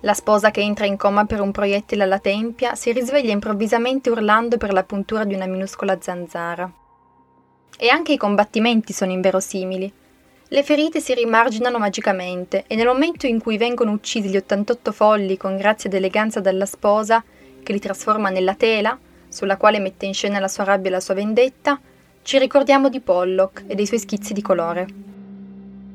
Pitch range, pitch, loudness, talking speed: 195-230 Hz, 205 Hz, -19 LUFS, 175 wpm